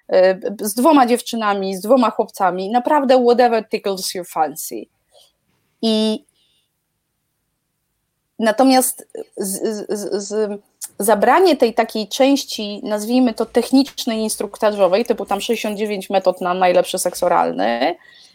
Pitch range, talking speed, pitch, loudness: 195-245 Hz, 105 wpm, 220 Hz, -17 LUFS